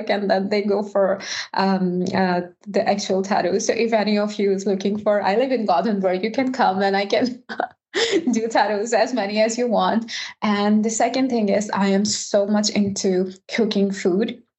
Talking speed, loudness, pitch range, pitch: 195 wpm, -21 LUFS, 195-225 Hz, 205 Hz